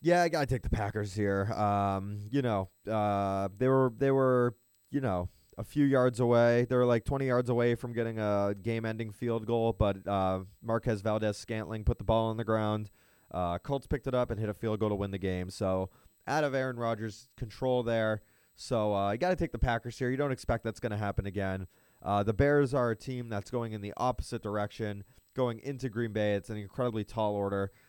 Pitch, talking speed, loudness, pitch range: 115 Hz, 215 wpm, -31 LUFS, 100-125 Hz